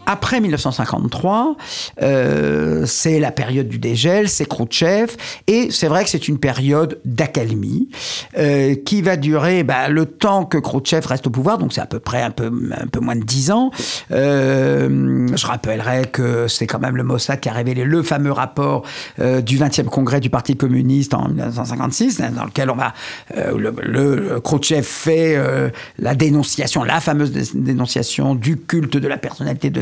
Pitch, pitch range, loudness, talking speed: 135 Hz, 125-155 Hz, -17 LUFS, 175 wpm